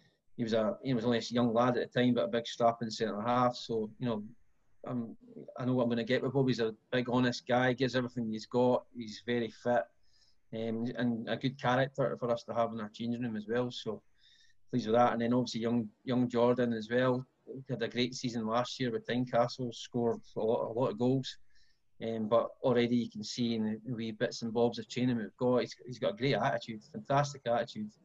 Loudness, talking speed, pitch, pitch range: -33 LUFS, 240 wpm, 120 Hz, 115-125 Hz